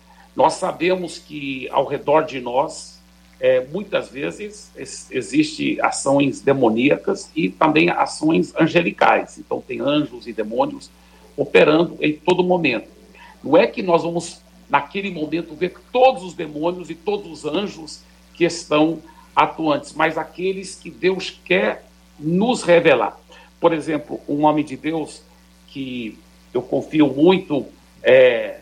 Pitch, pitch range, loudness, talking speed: 160 Hz, 140-185 Hz, -19 LUFS, 130 wpm